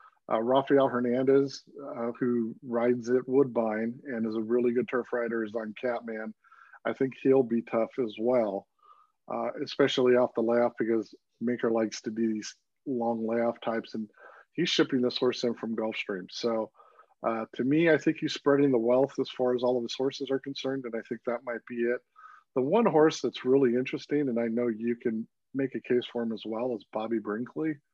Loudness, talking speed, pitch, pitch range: -29 LUFS, 200 wpm, 120 Hz, 115-135 Hz